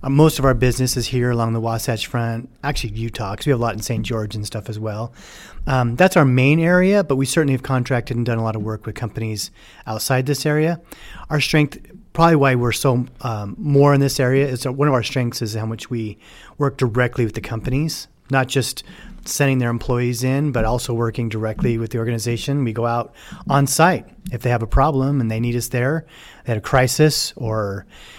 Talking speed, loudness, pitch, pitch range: 220 wpm, -19 LUFS, 125 Hz, 115-140 Hz